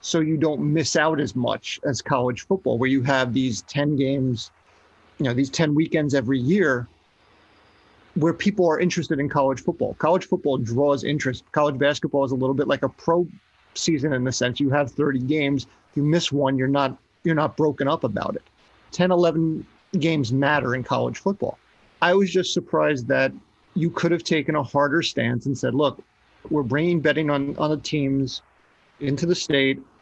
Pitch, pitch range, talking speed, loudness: 145 Hz, 130-160 Hz, 190 wpm, -23 LUFS